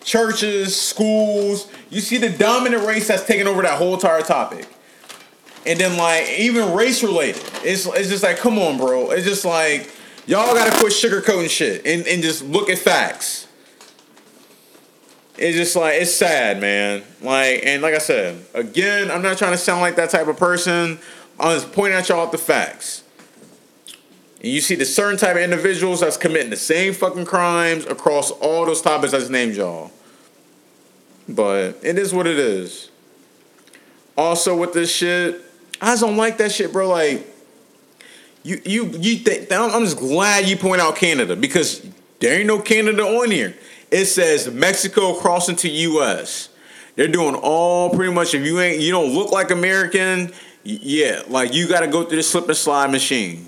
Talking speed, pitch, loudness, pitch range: 175 wpm, 180 Hz, -17 LUFS, 165-205 Hz